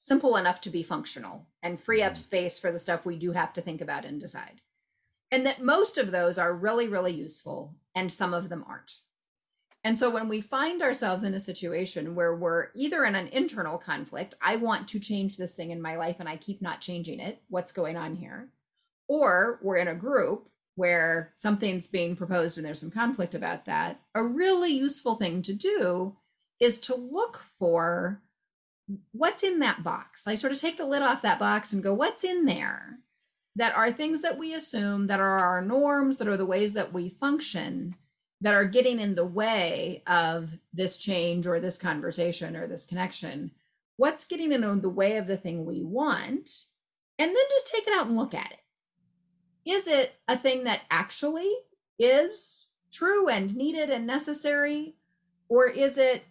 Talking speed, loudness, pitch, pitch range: 190 wpm, -28 LUFS, 205 Hz, 175-275 Hz